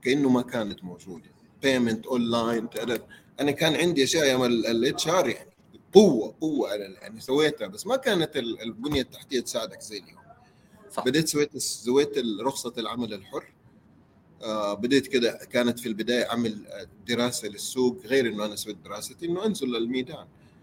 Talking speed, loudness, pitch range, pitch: 140 wpm, -26 LUFS, 110-135 Hz, 120 Hz